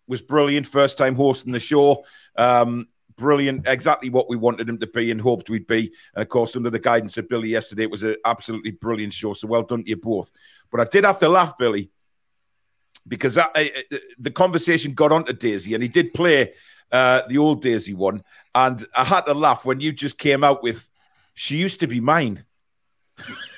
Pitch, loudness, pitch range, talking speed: 125 Hz, -20 LUFS, 115-145 Hz, 210 wpm